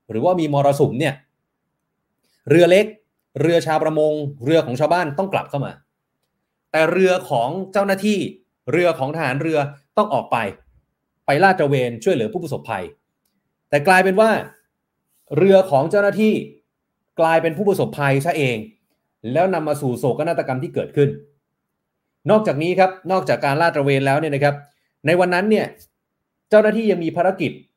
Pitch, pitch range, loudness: 160 Hz, 145-185 Hz, -18 LUFS